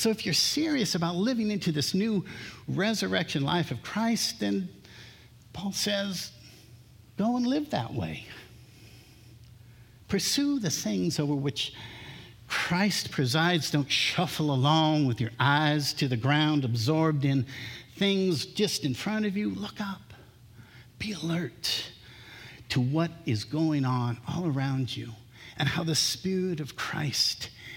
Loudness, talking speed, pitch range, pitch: -28 LUFS, 135 wpm, 120-175 Hz, 145 Hz